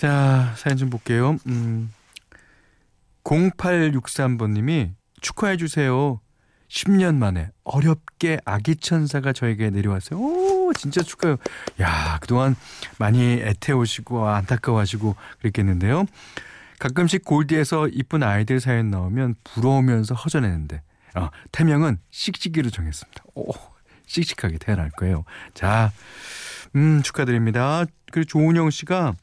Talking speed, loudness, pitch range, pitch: 275 characters per minute, -22 LUFS, 105-155 Hz, 130 Hz